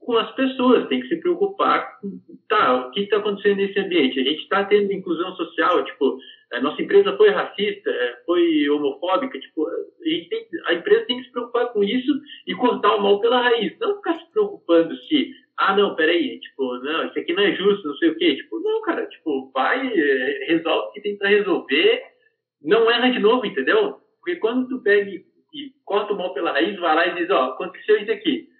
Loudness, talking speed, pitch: -21 LUFS, 205 wpm, 260 Hz